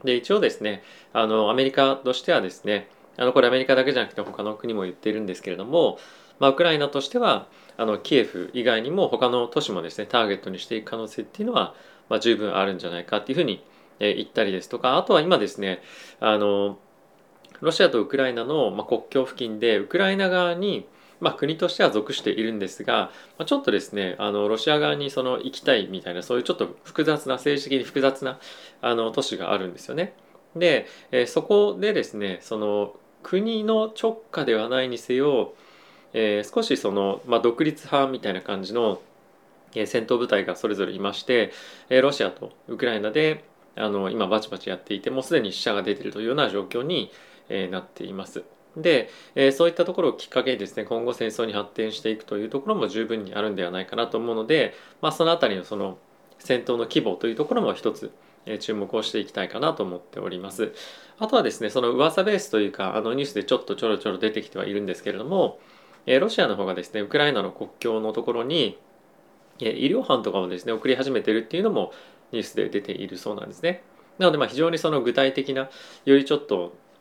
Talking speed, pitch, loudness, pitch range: 430 characters per minute, 120 Hz, -24 LUFS, 105-145 Hz